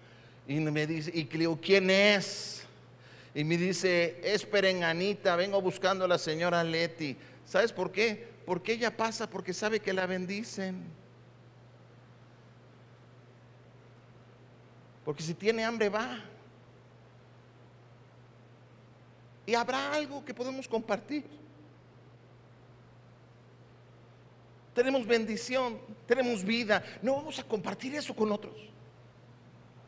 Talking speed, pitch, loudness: 100 wpm, 165 Hz, -31 LUFS